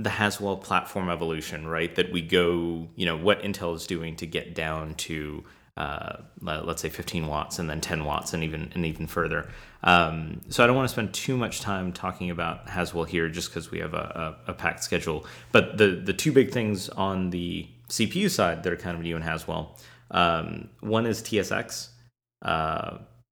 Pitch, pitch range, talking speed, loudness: 85 Hz, 80-100 Hz, 205 wpm, -27 LUFS